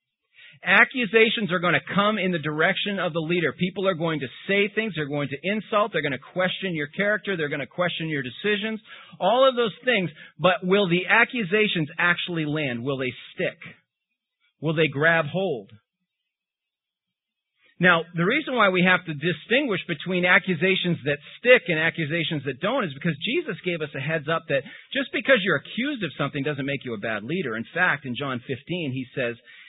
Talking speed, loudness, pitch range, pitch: 190 wpm, -23 LUFS, 155-205 Hz, 175 Hz